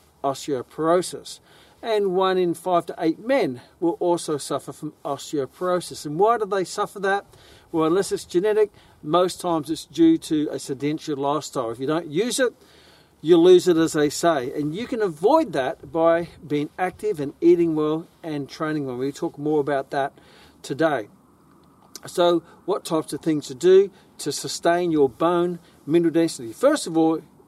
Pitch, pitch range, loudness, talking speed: 165 Hz, 150-185 Hz, -22 LUFS, 170 wpm